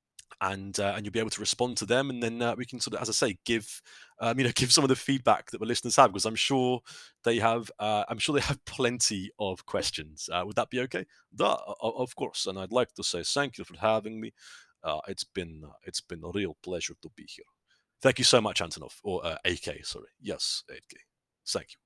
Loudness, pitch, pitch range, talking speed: -29 LUFS, 115 Hz, 105-130 Hz, 240 wpm